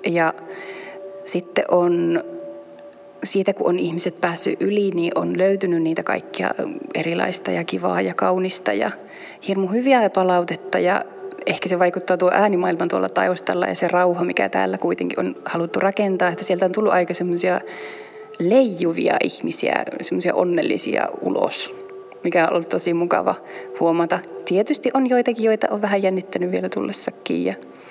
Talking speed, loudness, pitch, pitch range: 145 wpm, -20 LUFS, 185 Hz, 170-205 Hz